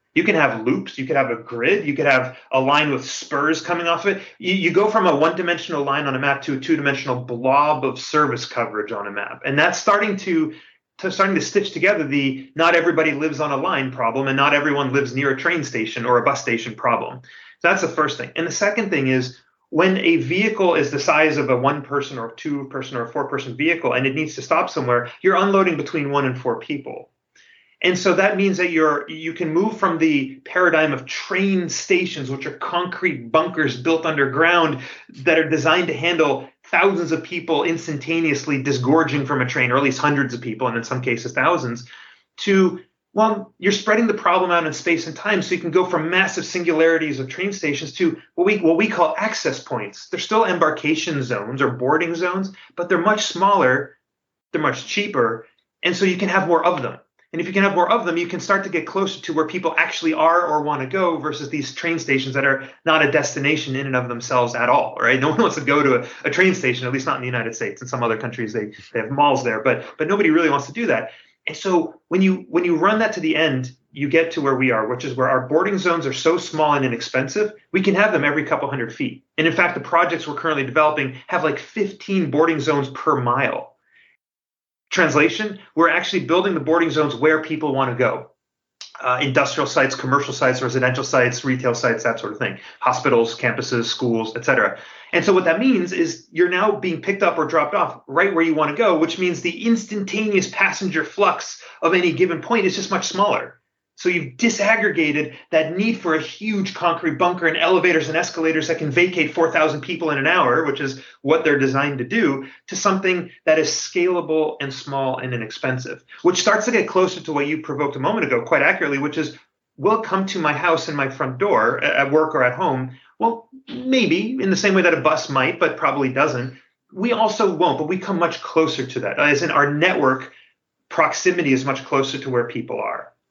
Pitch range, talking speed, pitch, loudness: 135-180 Hz, 225 wpm, 160 Hz, -19 LUFS